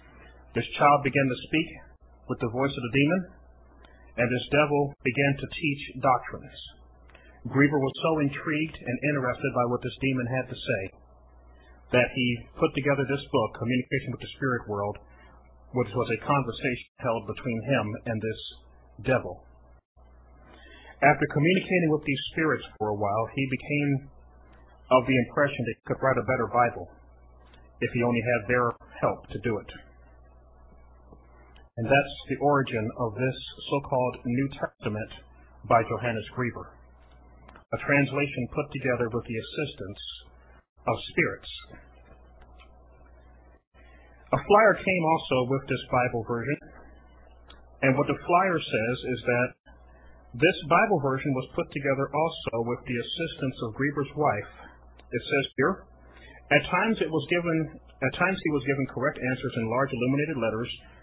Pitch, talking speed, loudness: 120 Hz, 145 wpm, -27 LUFS